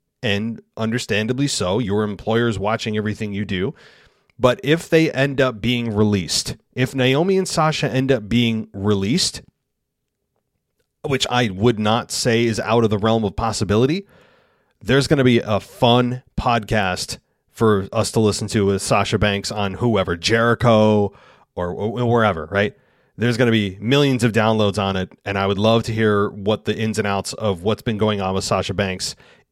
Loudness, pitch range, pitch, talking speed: -19 LUFS, 105-120 Hz, 110 Hz, 175 wpm